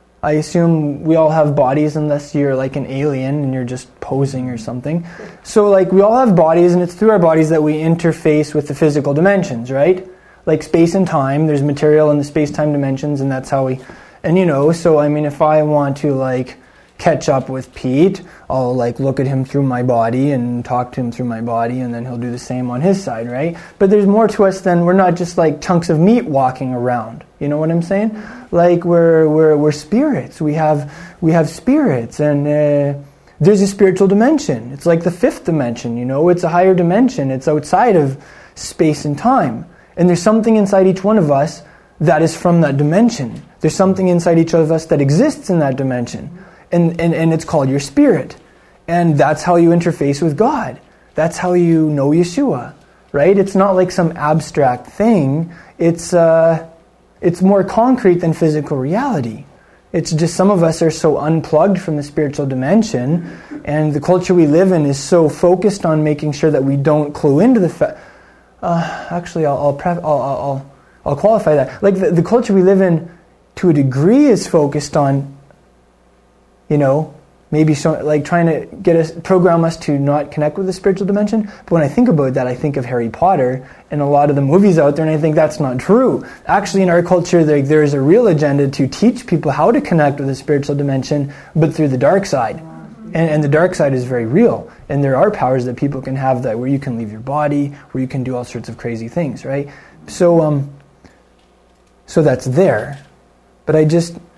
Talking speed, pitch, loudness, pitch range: 210 wpm, 155 Hz, -14 LUFS, 140-175 Hz